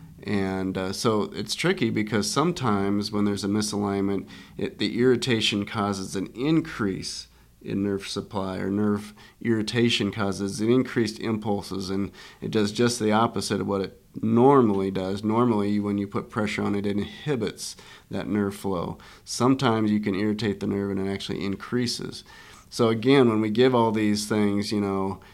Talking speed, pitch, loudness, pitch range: 165 wpm, 105 Hz, -25 LUFS, 100-115 Hz